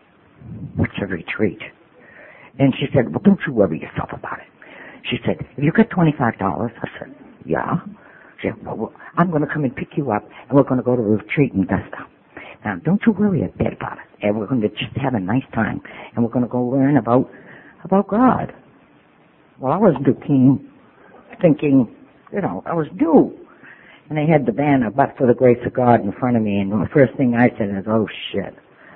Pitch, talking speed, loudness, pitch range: 135 Hz, 220 wpm, -19 LUFS, 120-155 Hz